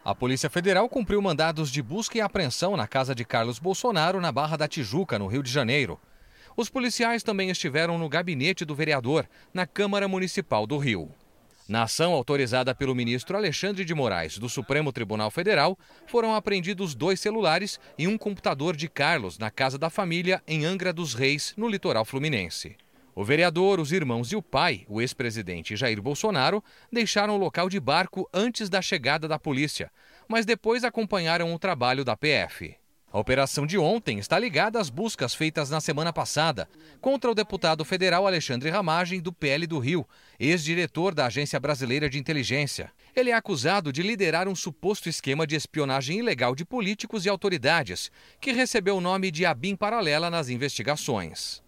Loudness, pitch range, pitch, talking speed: -26 LUFS, 135-195 Hz, 160 Hz, 170 wpm